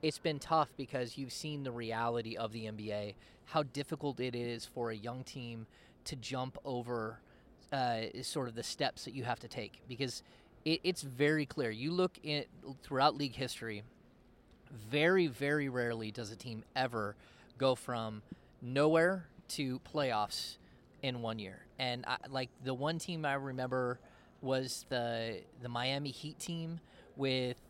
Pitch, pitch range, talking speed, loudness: 130 Hz, 115-145 Hz, 160 wpm, -37 LUFS